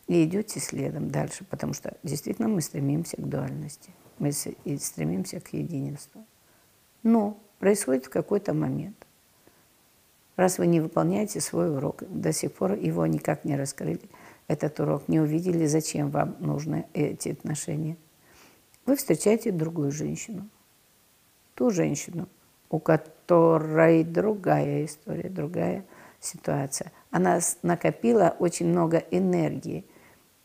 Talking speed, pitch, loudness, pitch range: 115 wpm, 165 Hz, -27 LUFS, 150-185 Hz